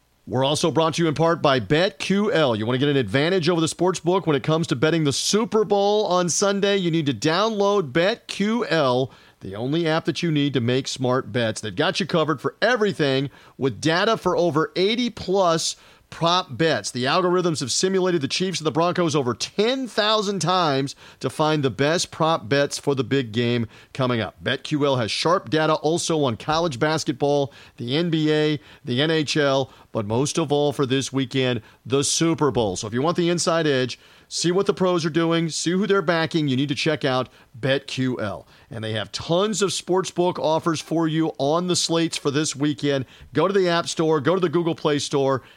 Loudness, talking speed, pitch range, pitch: -22 LUFS, 200 wpm, 135-175 Hz, 155 Hz